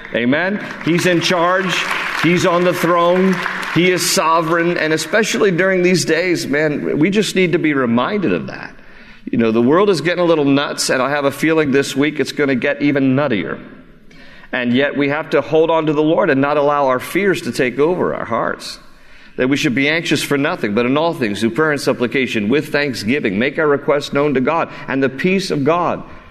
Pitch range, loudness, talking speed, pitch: 140-175 Hz, -16 LUFS, 215 wpm, 155 Hz